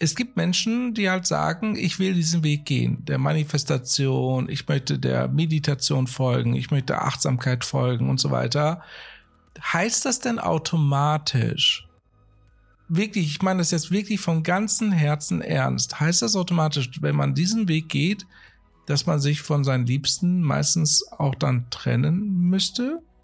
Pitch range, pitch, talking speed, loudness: 135-180 Hz, 155 Hz, 150 wpm, -23 LUFS